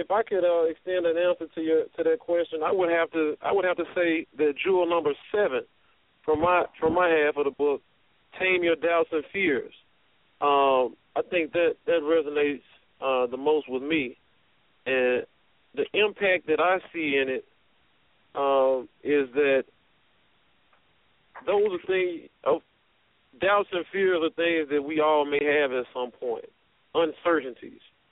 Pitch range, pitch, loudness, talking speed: 145-185 Hz, 165 Hz, -25 LUFS, 170 wpm